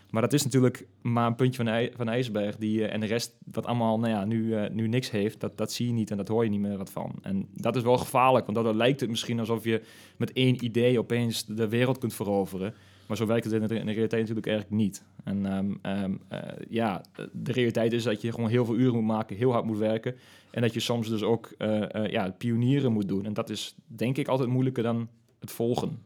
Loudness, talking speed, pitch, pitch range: -28 LUFS, 250 wpm, 115 Hz, 105-120 Hz